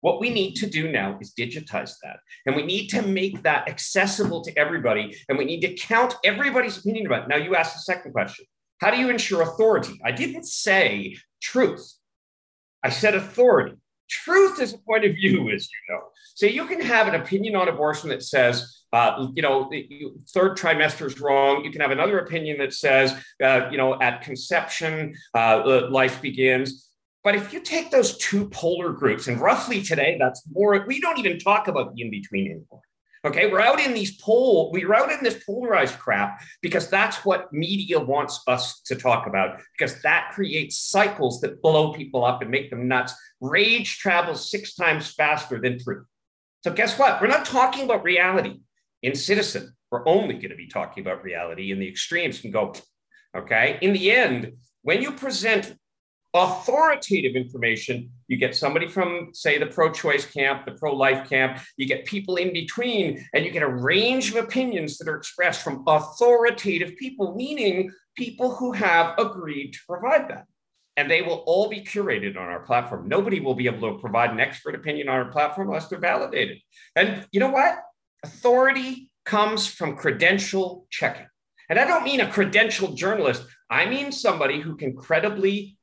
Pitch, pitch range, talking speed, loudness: 175 Hz, 135-220 Hz, 185 wpm, -22 LUFS